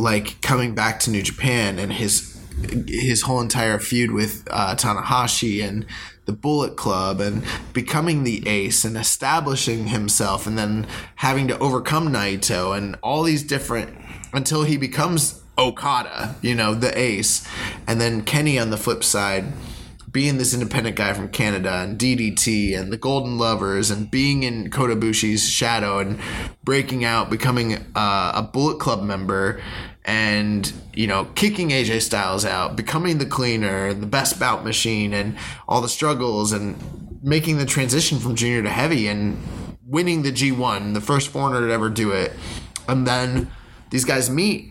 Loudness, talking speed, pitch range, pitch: -21 LUFS, 160 wpm, 105-130 Hz, 115 Hz